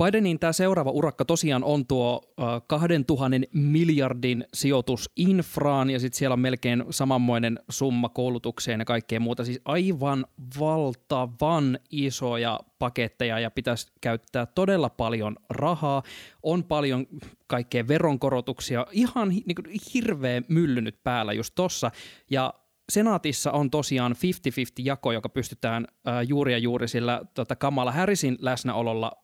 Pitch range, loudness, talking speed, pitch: 120-150 Hz, -26 LUFS, 115 wpm, 130 Hz